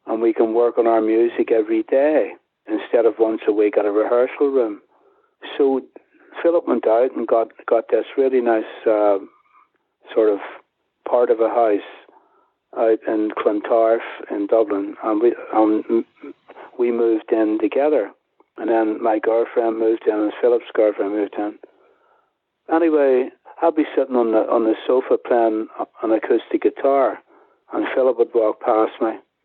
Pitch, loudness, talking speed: 165 Hz, -19 LUFS, 155 wpm